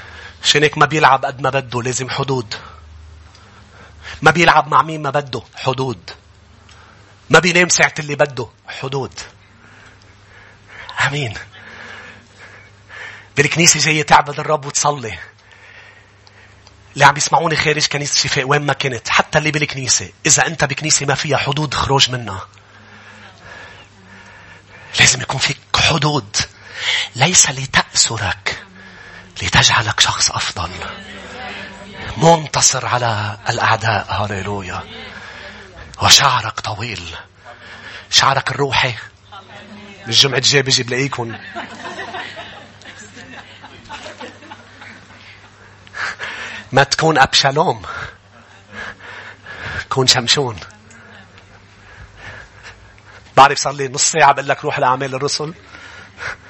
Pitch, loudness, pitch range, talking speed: 115 Hz, -14 LUFS, 100-140 Hz, 85 wpm